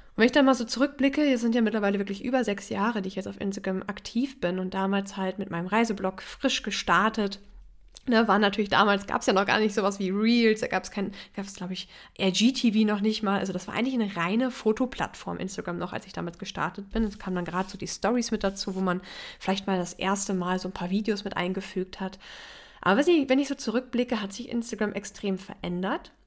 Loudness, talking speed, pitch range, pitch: -27 LUFS, 230 wpm, 190-230 Hz, 205 Hz